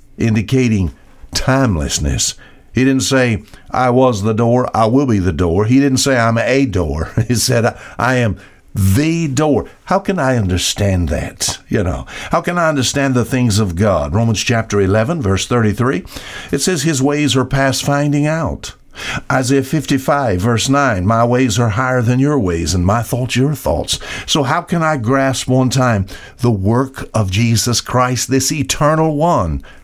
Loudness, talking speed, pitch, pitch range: -15 LUFS, 175 wpm, 125 Hz, 105-135 Hz